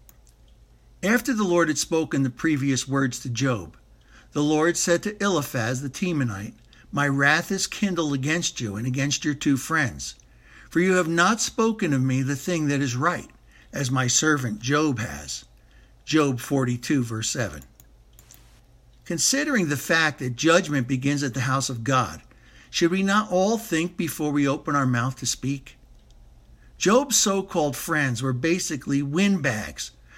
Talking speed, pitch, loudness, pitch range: 155 wpm, 145 Hz, -23 LUFS, 130-170 Hz